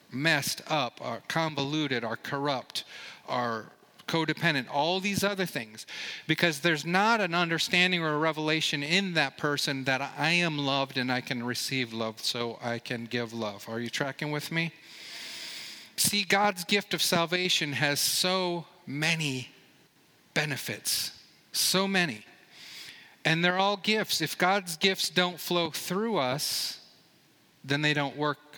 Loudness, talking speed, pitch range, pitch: -28 LUFS, 145 wpm, 135-180 Hz, 155 Hz